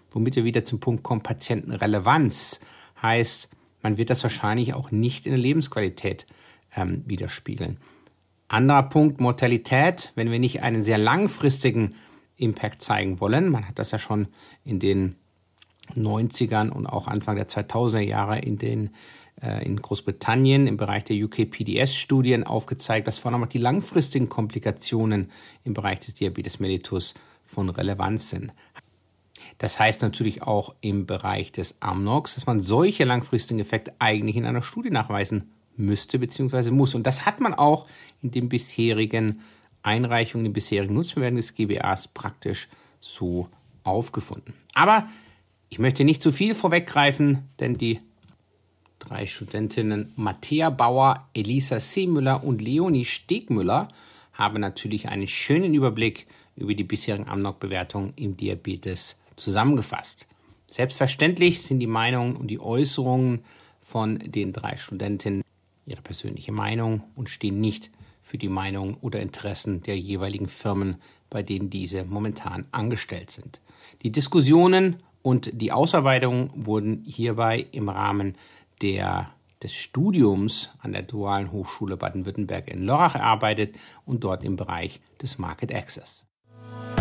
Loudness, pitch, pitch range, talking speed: -24 LUFS, 110 Hz, 105-130 Hz, 135 wpm